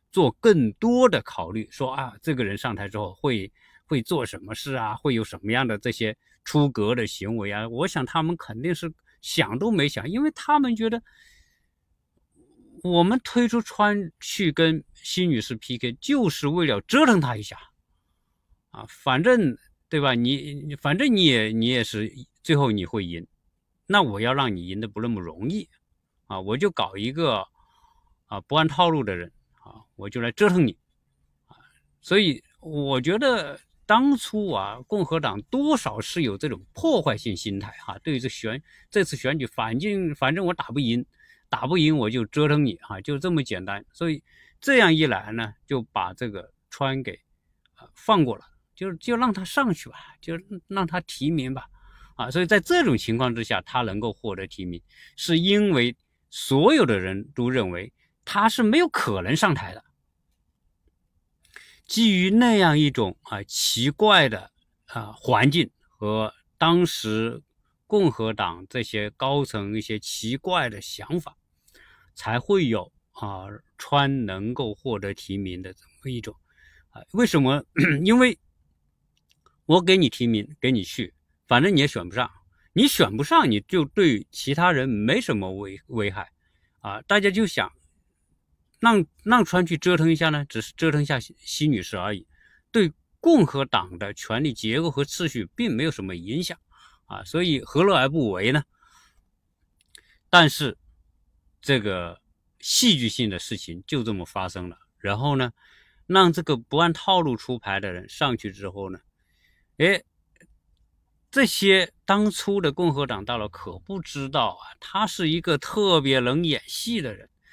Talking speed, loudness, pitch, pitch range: 225 characters per minute, -23 LUFS, 130 Hz, 105-175 Hz